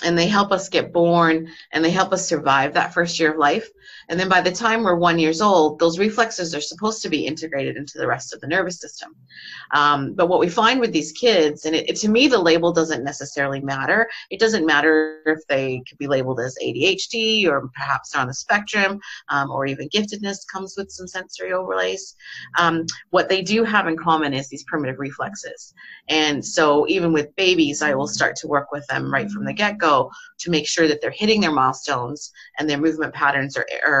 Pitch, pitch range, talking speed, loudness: 165 Hz, 145-195 Hz, 215 wpm, -20 LUFS